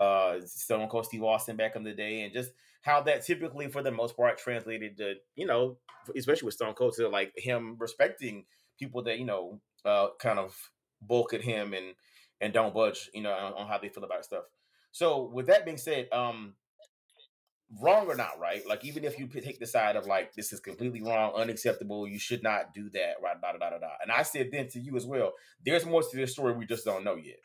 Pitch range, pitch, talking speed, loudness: 110-140 Hz, 120 Hz, 230 wpm, -31 LUFS